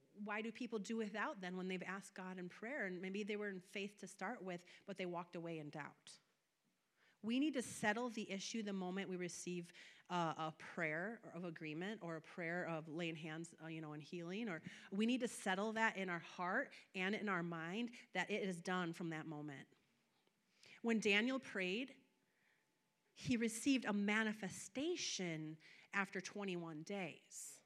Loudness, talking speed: -44 LUFS, 180 wpm